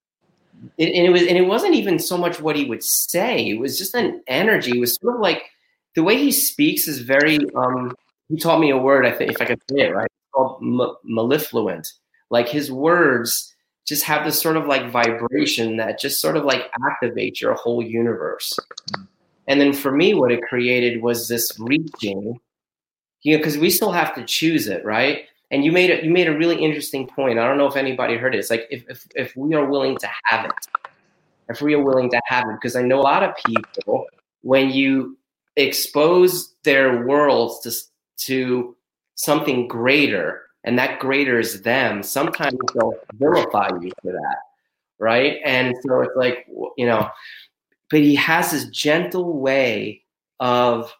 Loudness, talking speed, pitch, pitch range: -19 LUFS, 190 wpm, 135 Hz, 125-160 Hz